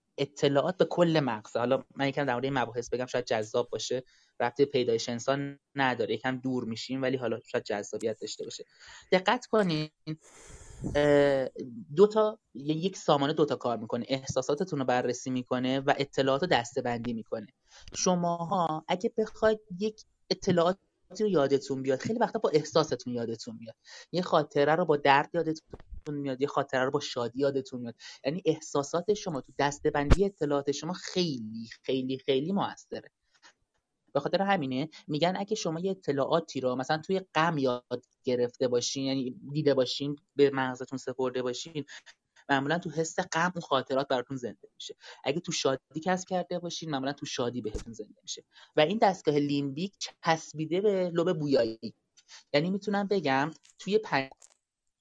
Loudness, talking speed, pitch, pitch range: -30 LUFS, 155 wpm, 145 Hz, 130-175 Hz